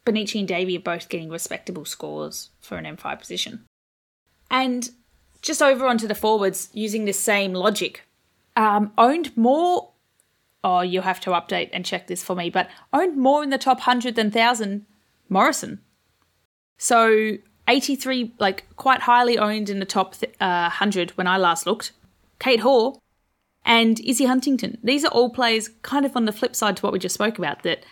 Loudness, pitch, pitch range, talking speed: -21 LUFS, 215 Hz, 185-245 Hz, 175 wpm